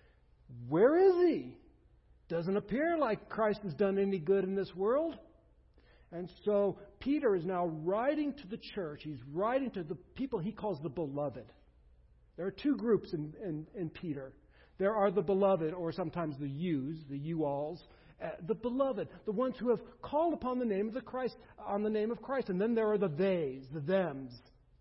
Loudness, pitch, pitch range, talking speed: -34 LUFS, 195 Hz, 160-225 Hz, 190 wpm